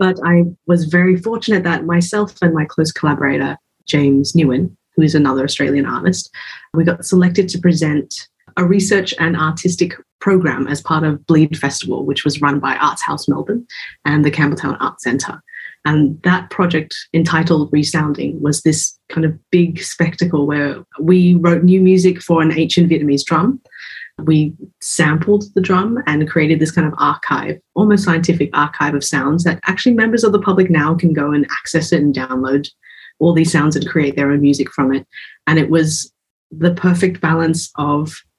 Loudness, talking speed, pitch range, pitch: -15 LUFS, 175 wpm, 145-180 Hz, 160 Hz